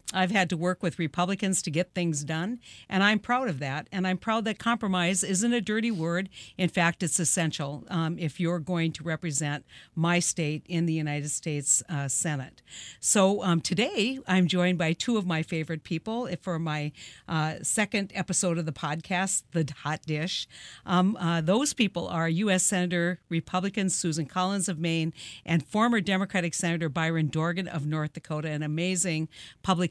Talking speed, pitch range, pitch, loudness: 175 wpm, 160-190 Hz, 175 Hz, -28 LUFS